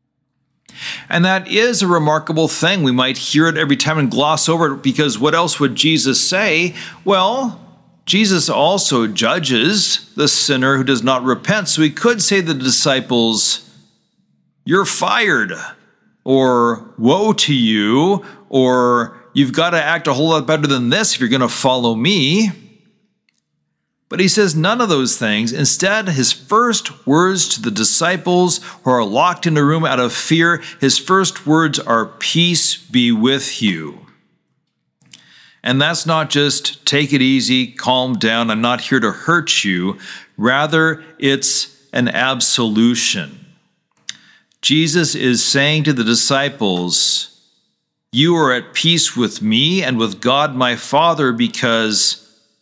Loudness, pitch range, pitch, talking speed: -14 LUFS, 125-170 Hz, 145 Hz, 150 wpm